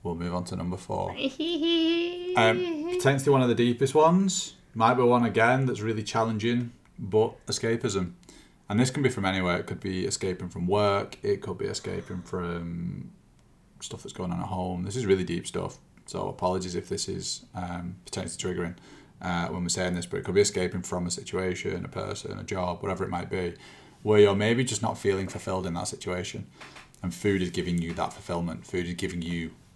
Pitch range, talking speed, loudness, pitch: 90-120 Hz, 200 wpm, -28 LUFS, 95 Hz